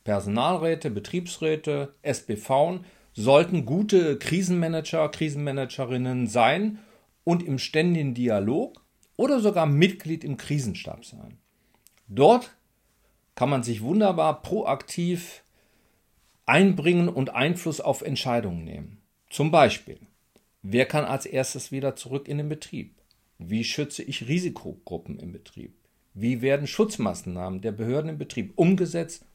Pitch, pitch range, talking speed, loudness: 145 Hz, 125-175 Hz, 110 wpm, -25 LUFS